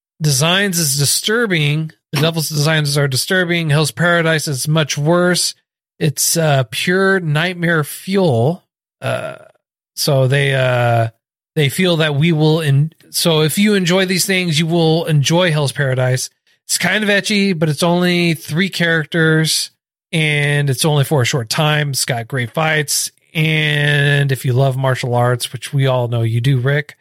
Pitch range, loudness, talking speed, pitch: 140-170 Hz, -15 LUFS, 160 wpm, 155 Hz